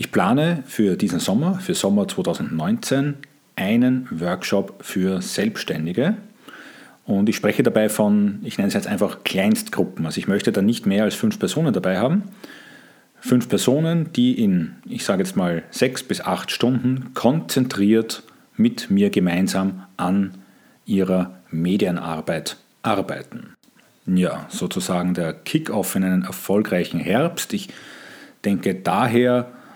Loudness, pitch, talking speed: -21 LUFS, 125 Hz, 130 wpm